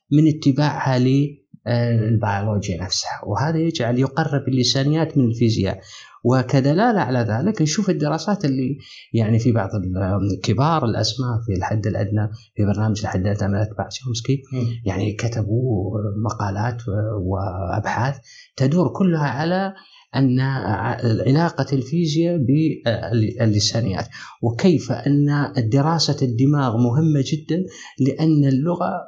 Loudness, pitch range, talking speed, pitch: -20 LUFS, 110-145 Hz, 100 wpm, 125 Hz